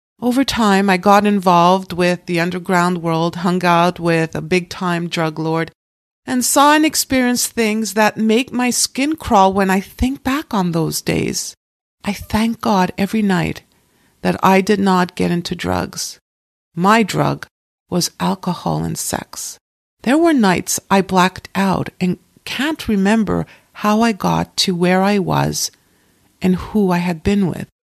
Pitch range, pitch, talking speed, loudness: 175-220 Hz, 190 Hz, 160 wpm, -16 LUFS